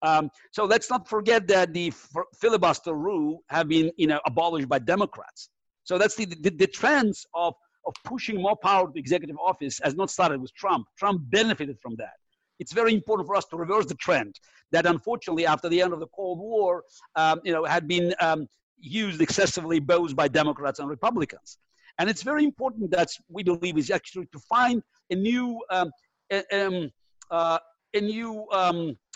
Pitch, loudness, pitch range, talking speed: 180 Hz, -25 LUFS, 165-210 Hz, 185 wpm